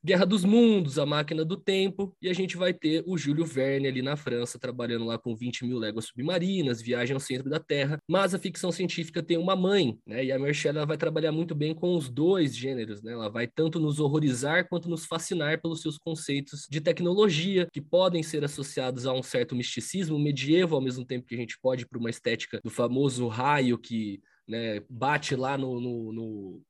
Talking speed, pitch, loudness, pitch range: 210 wpm, 145 Hz, -28 LUFS, 125-170 Hz